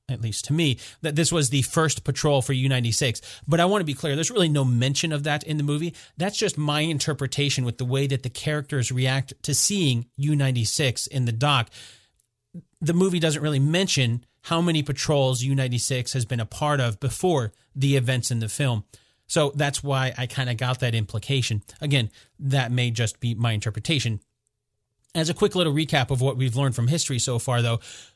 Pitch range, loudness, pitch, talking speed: 120-150 Hz, -24 LUFS, 135 Hz, 205 wpm